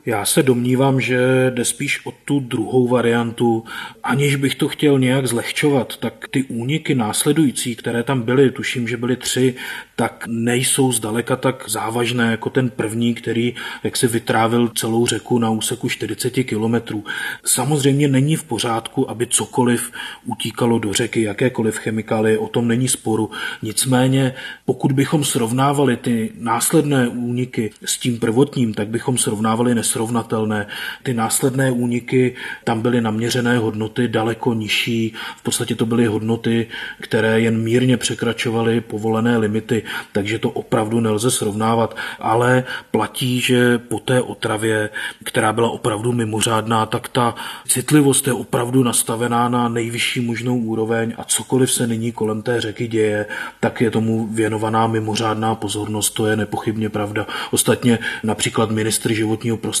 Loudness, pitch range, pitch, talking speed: -19 LUFS, 110-125 Hz, 120 Hz, 140 wpm